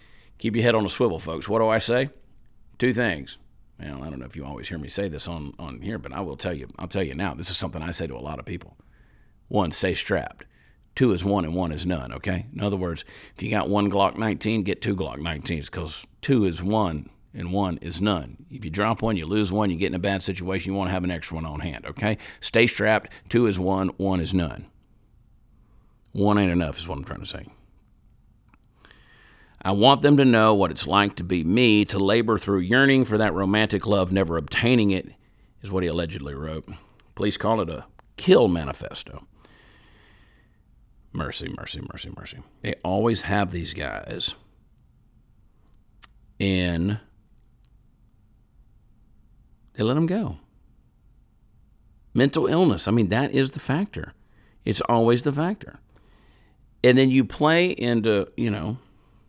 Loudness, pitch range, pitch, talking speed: -24 LUFS, 85-110 Hz, 100 Hz, 185 wpm